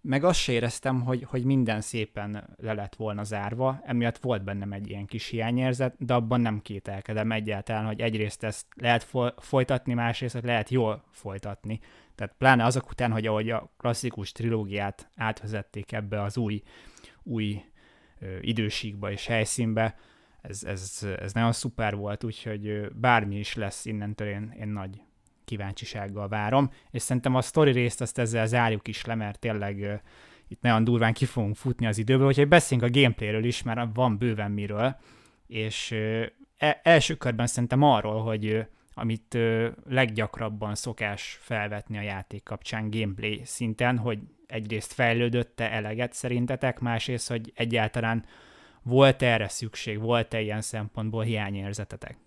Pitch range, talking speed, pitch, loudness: 105-120 Hz, 145 wpm, 115 Hz, -28 LUFS